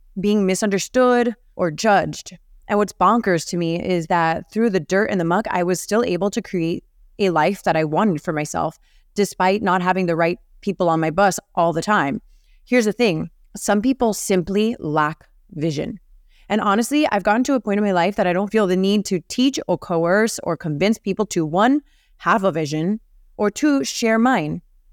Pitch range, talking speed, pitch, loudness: 175-215 Hz, 195 wpm, 195 Hz, -20 LUFS